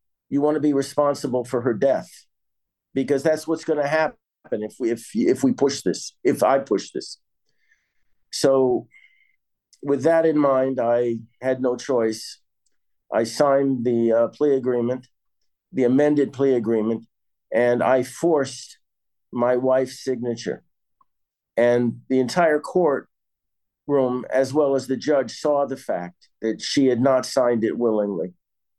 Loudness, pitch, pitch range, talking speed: -22 LUFS, 130 Hz, 120-145 Hz, 145 wpm